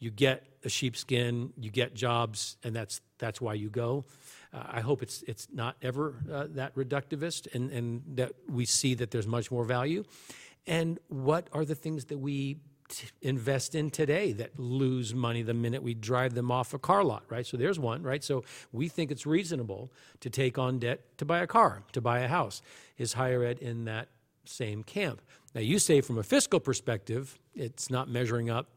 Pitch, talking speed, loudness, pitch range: 130 Hz, 200 wpm, -32 LUFS, 120-140 Hz